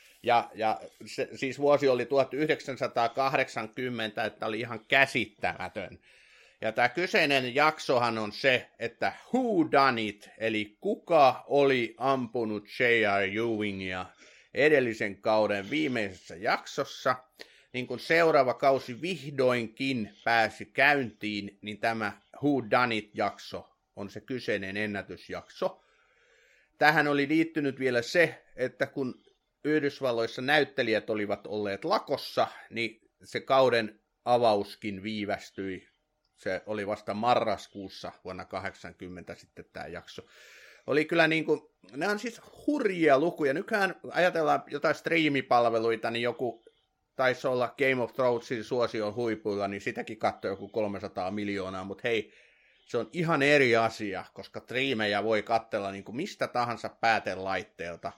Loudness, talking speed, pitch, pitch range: -28 LUFS, 115 wpm, 120 Hz, 105-140 Hz